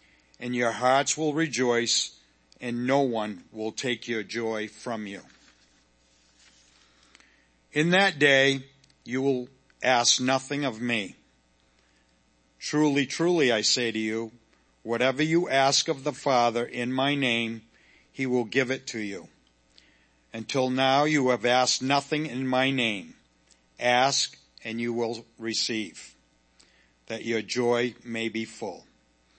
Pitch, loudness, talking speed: 115 Hz, -26 LUFS, 130 wpm